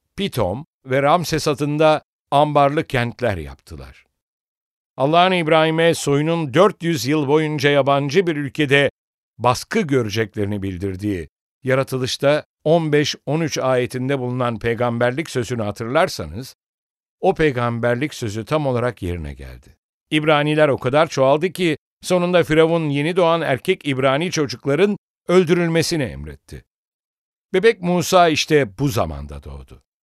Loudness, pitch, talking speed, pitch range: -19 LUFS, 140 Hz, 105 wpm, 120-160 Hz